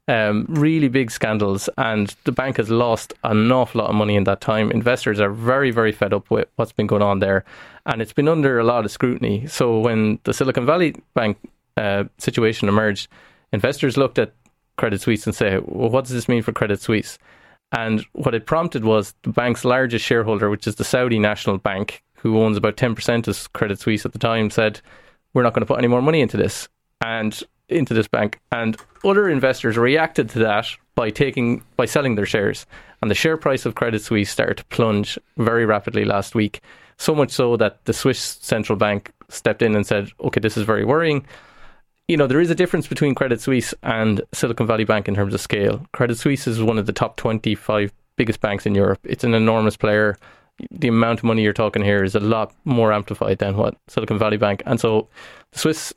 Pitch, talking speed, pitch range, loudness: 115 Hz, 210 wpm, 105-125 Hz, -20 LUFS